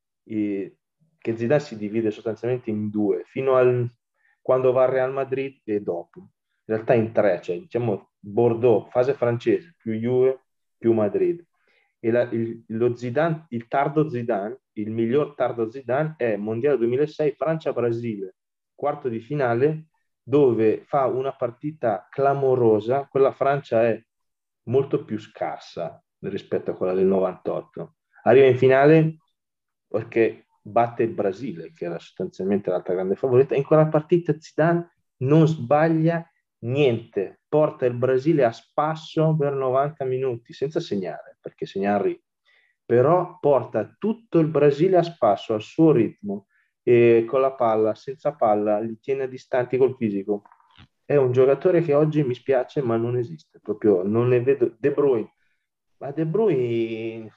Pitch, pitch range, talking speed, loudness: 130 Hz, 115-155 Hz, 140 wpm, -22 LUFS